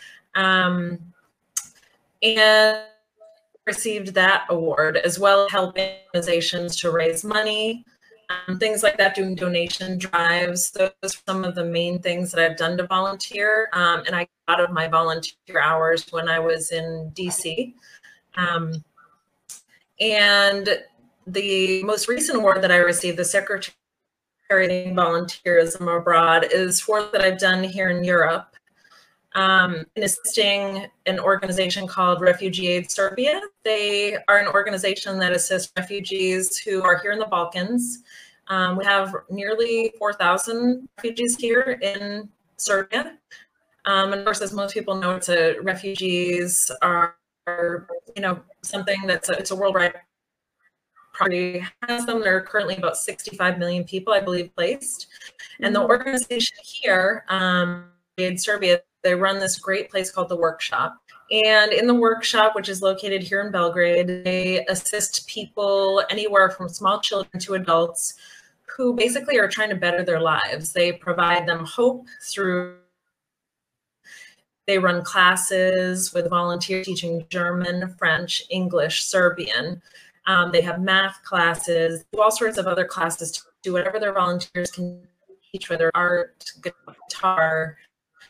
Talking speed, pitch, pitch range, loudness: 140 wpm, 185 Hz, 175-205 Hz, -21 LUFS